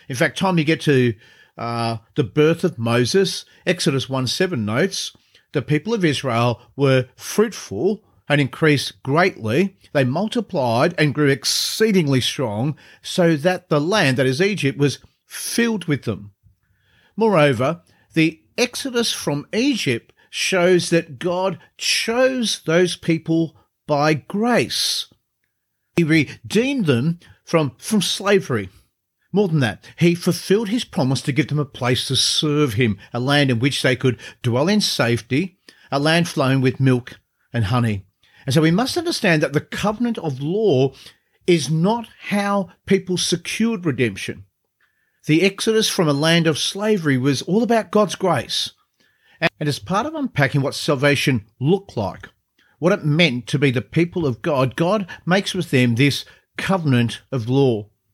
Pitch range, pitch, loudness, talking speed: 130-185 Hz, 150 Hz, -19 LUFS, 150 wpm